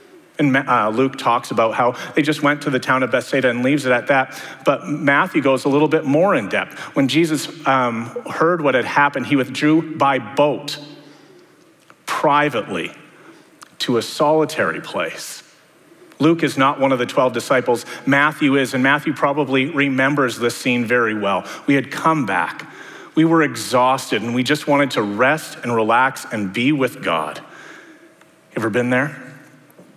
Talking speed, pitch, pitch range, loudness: 170 wpm, 140 Hz, 130-150 Hz, -18 LUFS